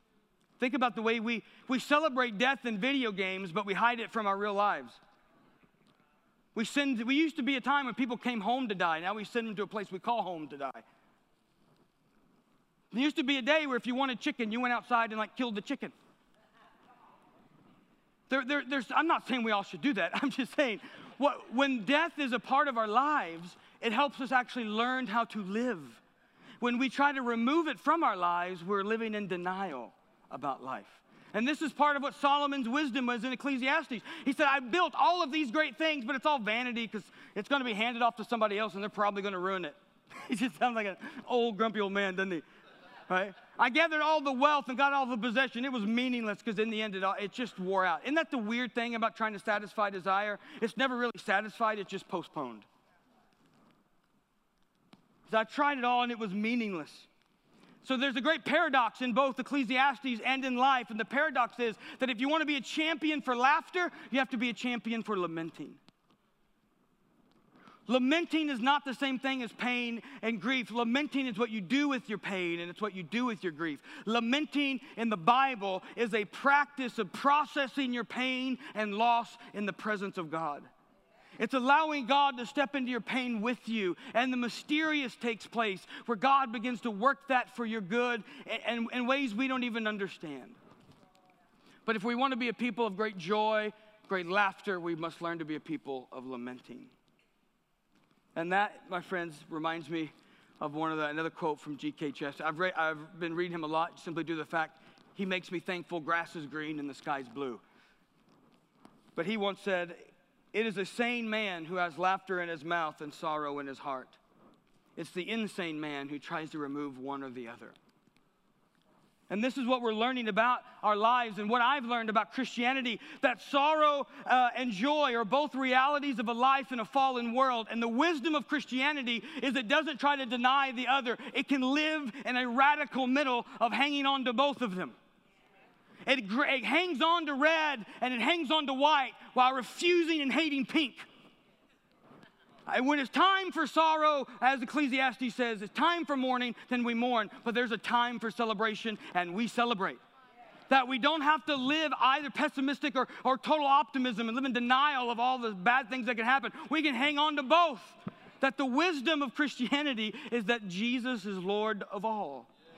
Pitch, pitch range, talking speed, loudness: 240 Hz, 210-275 Hz, 205 wpm, -31 LUFS